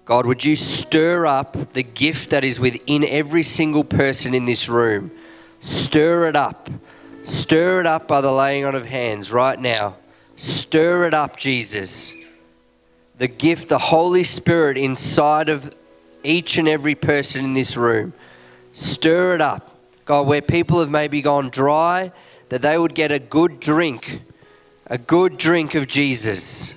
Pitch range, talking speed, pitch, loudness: 125-160 Hz, 155 wpm, 145 Hz, -18 LUFS